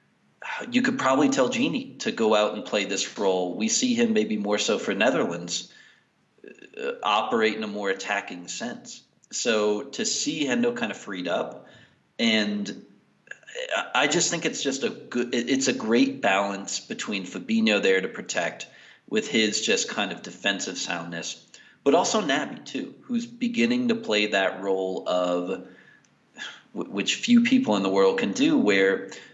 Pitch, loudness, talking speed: 220 Hz, -25 LUFS, 160 wpm